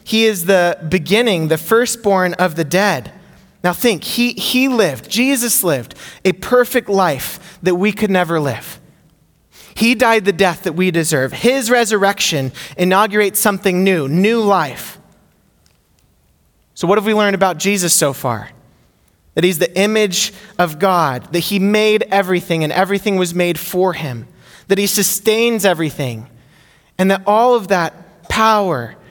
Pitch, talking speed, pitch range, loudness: 185 Hz, 150 wpm, 165-210 Hz, -15 LUFS